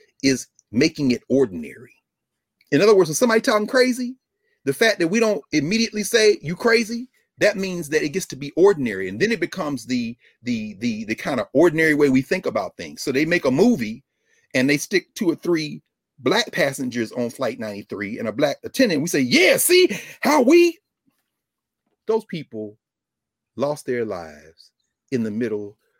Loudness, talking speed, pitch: -20 LUFS, 180 wpm, 165 Hz